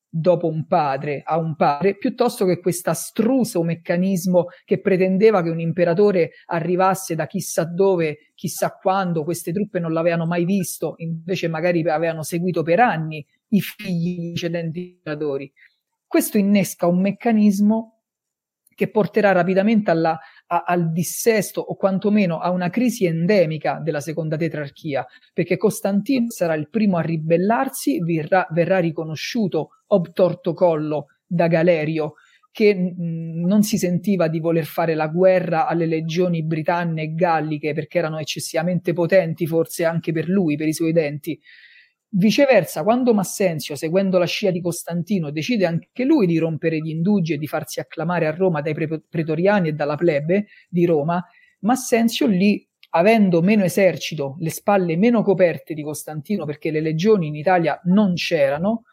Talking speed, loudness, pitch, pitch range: 150 wpm, -20 LUFS, 175 Hz, 165-200 Hz